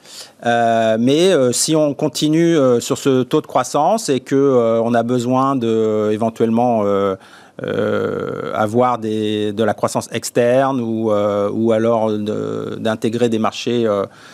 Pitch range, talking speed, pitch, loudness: 110-130 Hz, 145 wpm, 115 Hz, -17 LUFS